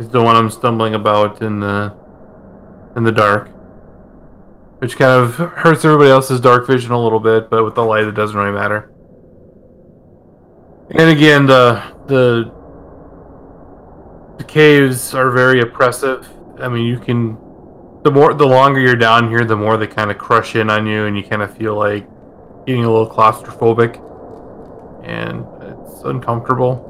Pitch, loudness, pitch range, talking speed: 115 Hz, -13 LUFS, 105-125 Hz, 160 wpm